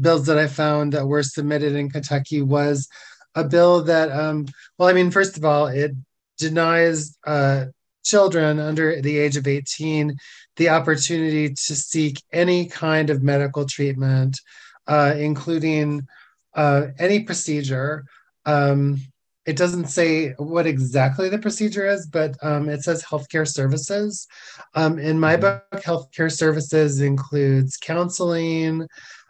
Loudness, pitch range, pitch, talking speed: -20 LUFS, 145-165 Hz, 155 Hz, 135 wpm